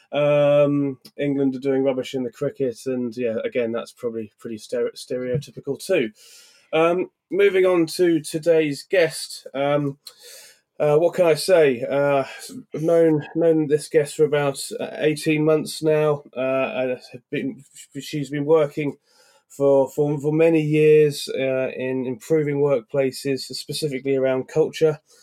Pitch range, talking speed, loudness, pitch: 135-155 Hz, 135 wpm, -21 LUFS, 145 Hz